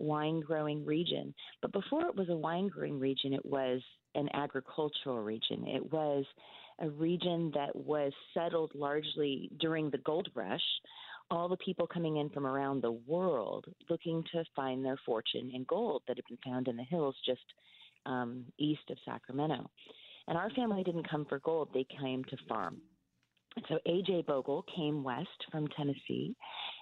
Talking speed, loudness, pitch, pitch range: 165 wpm, -37 LUFS, 150 Hz, 135-165 Hz